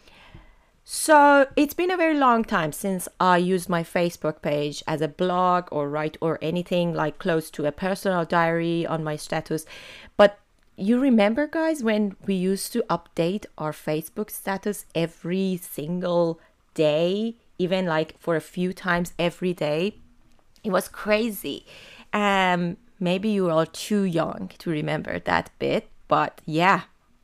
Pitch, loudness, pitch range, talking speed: 180 Hz, -24 LUFS, 160-205 Hz, 150 wpm